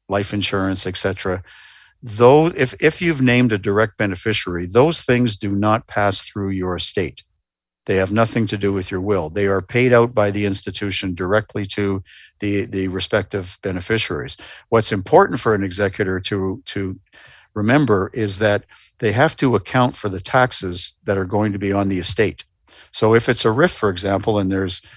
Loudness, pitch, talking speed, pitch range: -19 LUFS, 100 Hz, 180 wpm, 95-115 Hz